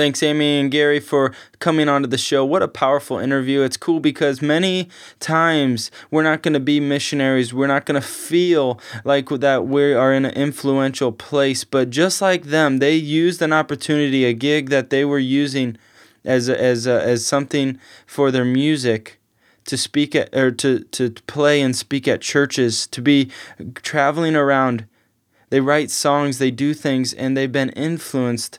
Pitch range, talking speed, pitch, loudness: 130-150 Hz, 175 wpm, 140 Hz, -18 LUFS